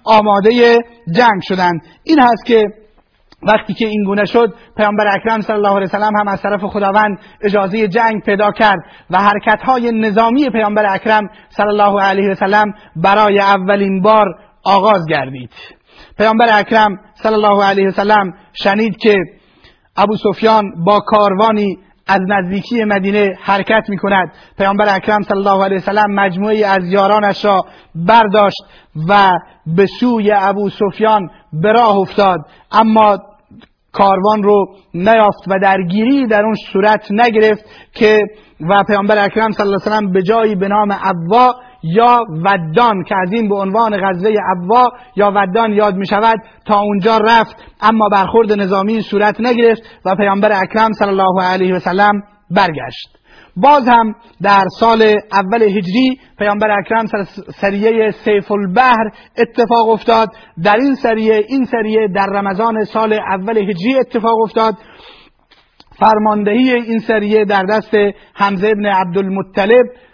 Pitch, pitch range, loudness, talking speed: 210 Hz, 195-220 Hz, -12 LUFS, 140 wpm